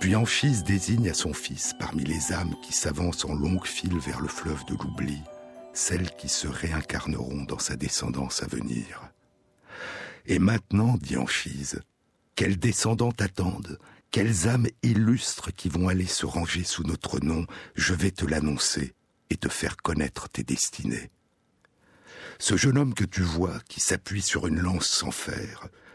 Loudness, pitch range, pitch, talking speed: -27 LUFS, 75-100 Hz, 90 Hz, 160 wpm